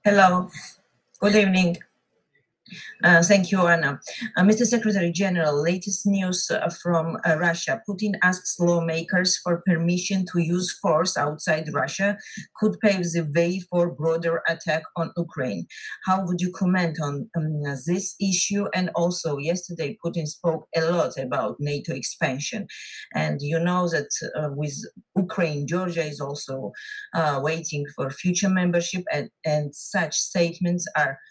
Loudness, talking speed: -23 LUFS, 140 wpm